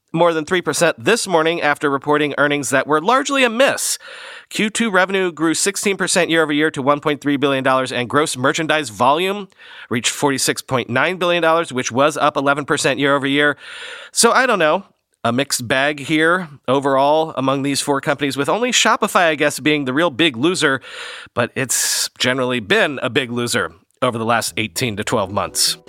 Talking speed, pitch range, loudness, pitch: 170 wpm, 135-170 Hz, -17 LUFS, 150 Hz